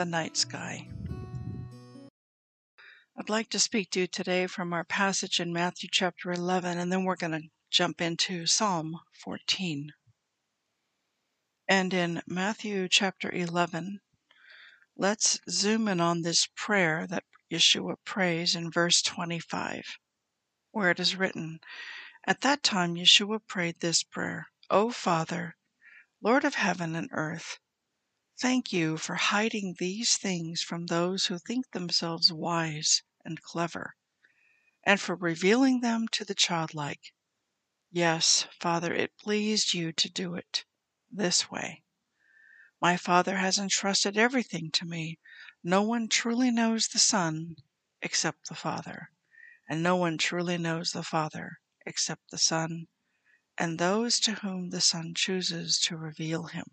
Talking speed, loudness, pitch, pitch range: 135 wpm, -28 LUFS, 180 Hz, 165-205 Hz